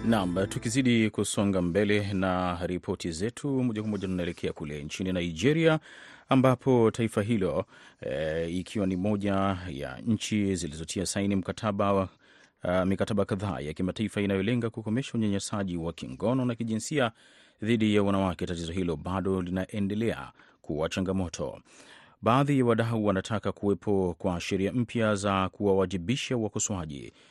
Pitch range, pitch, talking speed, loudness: 95-110 Hz, 100 Hz, 125 wpm, -29 LUFS